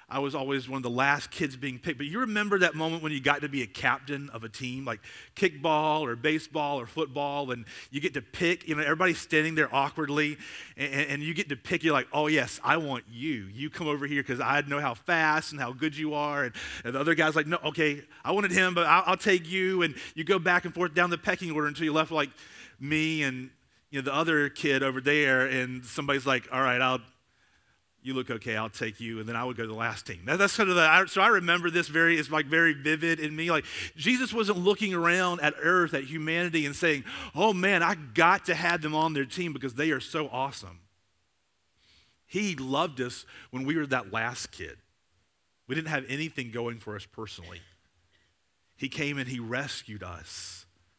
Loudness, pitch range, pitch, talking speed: -27 LUFS, 125-165 Hz, 145 Hz, 230 wpm